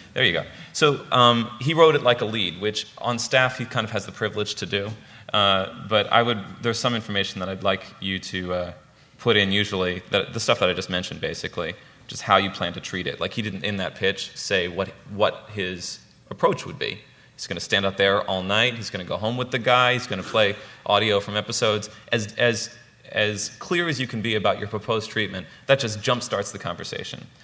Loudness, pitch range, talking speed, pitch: -23 LUFS, 95-120 Hz, 235 wpm, 105 Hz